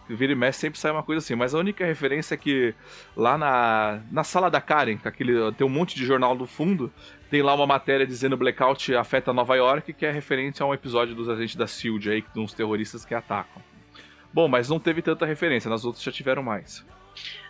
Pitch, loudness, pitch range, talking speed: 130 Hz, -24 LUFS, 115-155 Hz, 215 wpm